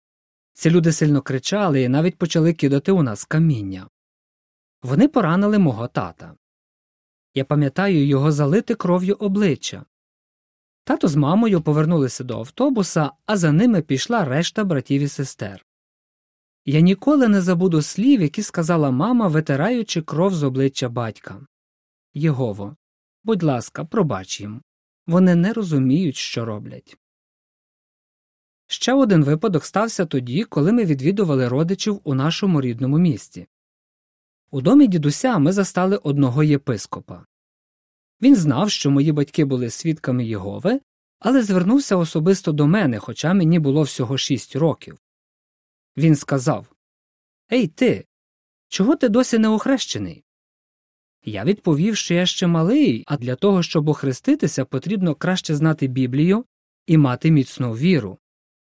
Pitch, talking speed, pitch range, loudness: 160 Hz, 130 wpm, 135-195 Hz, -19 LUFS